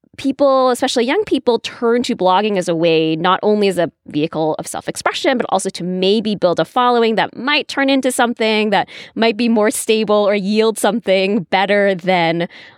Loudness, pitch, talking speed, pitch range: -16 LUFS, 210 Hz, 190 wpm, 185-240 Hz